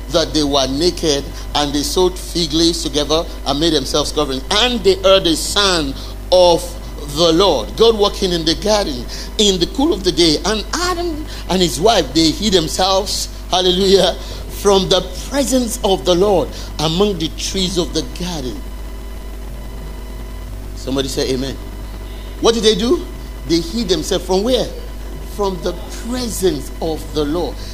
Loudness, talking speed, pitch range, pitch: -16 LUFS, 155 wpm, 150-200 Hz, 175 Hz